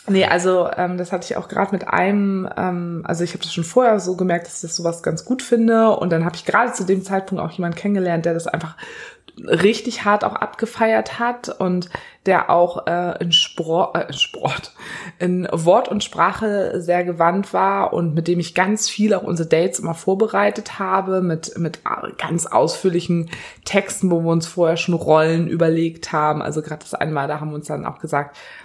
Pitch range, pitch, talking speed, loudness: 170-195 Hz, 180 Hz, 200 wpm, -19 LUFS